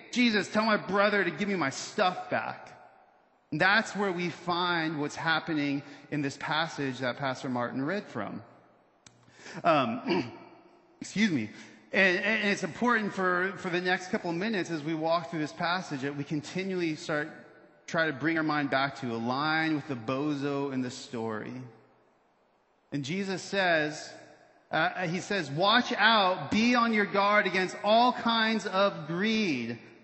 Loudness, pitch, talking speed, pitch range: -29 LUFS, 170 Hz, 160 wpm, 145-200 Hz